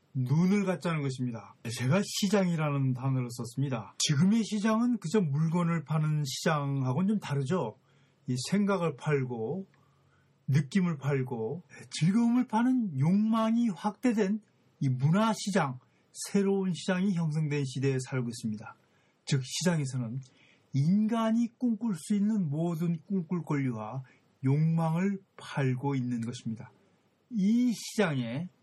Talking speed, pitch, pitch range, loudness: 265 characters per minute, 155 Hz, 135-200 Hz, -30 LUFS